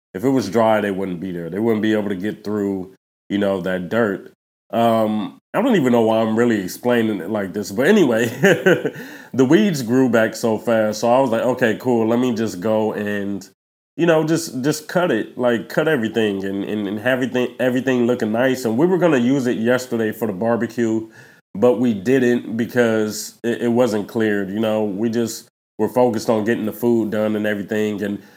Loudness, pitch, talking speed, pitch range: -19 LUFS, 110 Hz, 210 wpm, 105-120 Hz